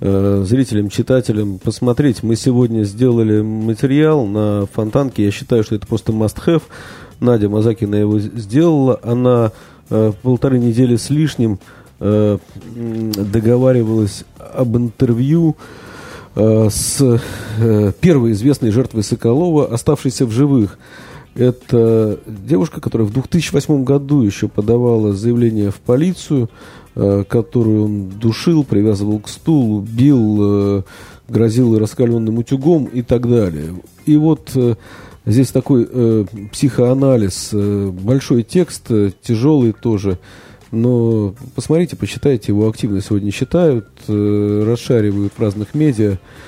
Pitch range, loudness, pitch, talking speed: 105-130 Hz, -15 LUFS, 115 Hz, 105 wpm